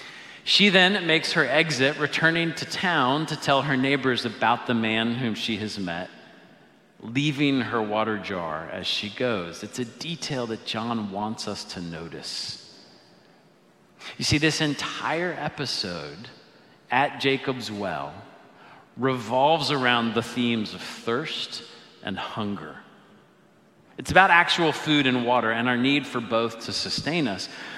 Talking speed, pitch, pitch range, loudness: 140 wpm, 125 Hz, 110-150 Hz, -24 LUFS